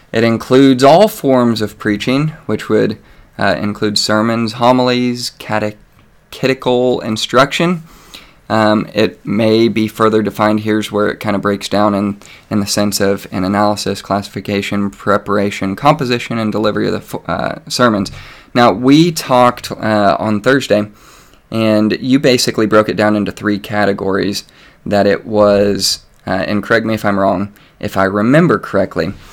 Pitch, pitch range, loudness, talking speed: 105 Hz, 100-120 Hz, -14 LUFS, 145 wpm